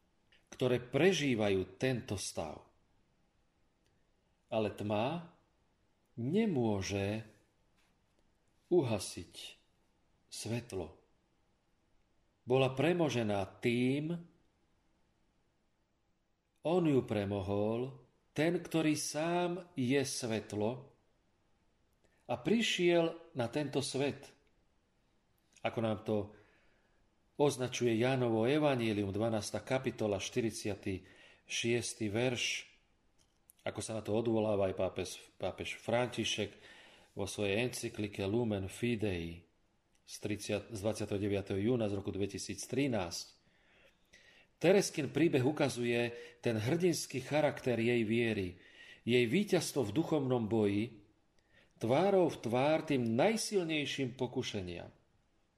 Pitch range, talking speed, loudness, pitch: 105-140 Hz, 80 wpm, -35 LUFS, 115 Hz